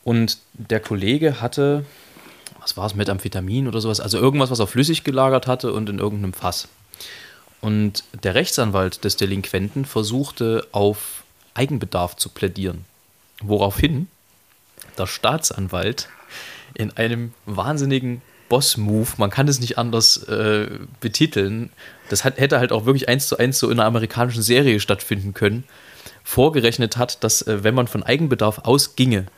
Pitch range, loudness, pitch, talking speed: 100-130 Hz, -20 LUFS, 115 Hz, 145 wpm